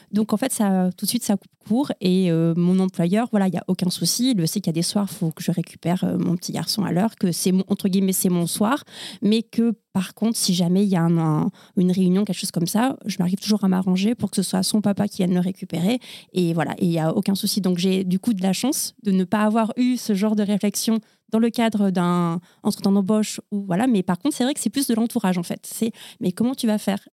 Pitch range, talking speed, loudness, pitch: 185-220 Hz, 285 wpm, -22 LUFS, 200 Hz